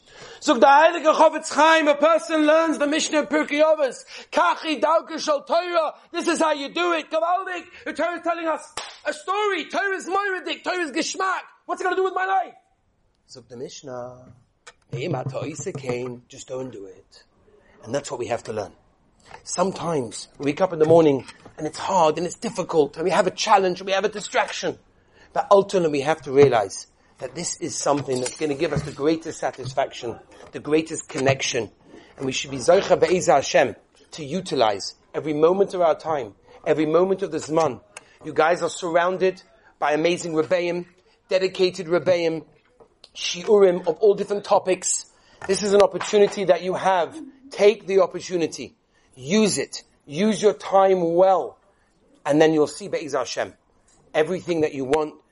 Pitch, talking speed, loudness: 190 Hz, 175 wpm, -22 LUFS